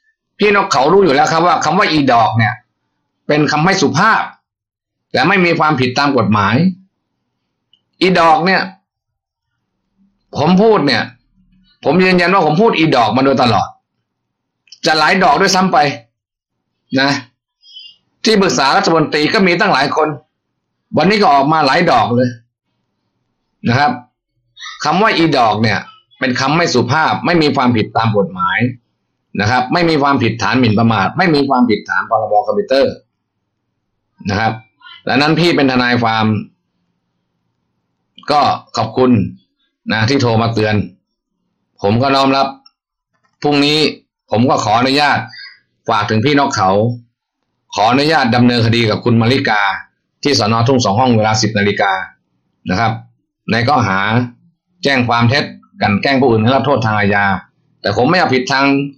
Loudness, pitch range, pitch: -13 LUFS, 115-160 Hz, 135 Hz